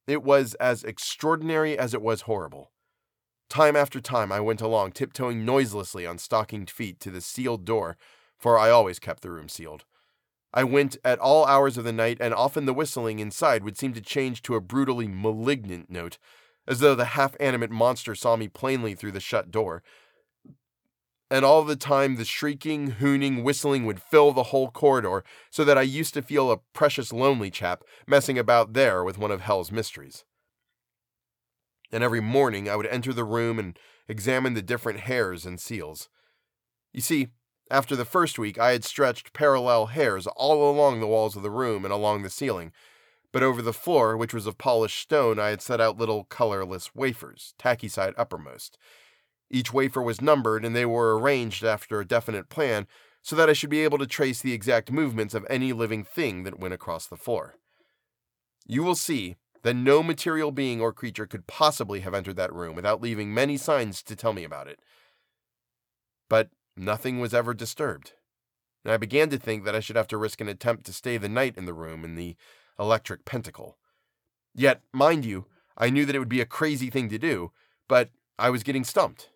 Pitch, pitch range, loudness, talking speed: 120 Hz, 110-135 Hz, -25 LUFS, 195 wpm